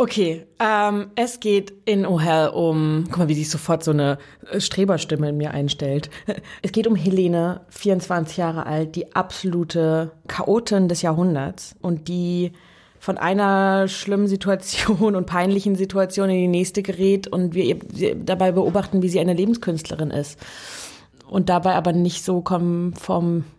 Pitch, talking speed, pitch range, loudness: 180 Hz, 155 wpm, 165-195 Hz, -21 LUFS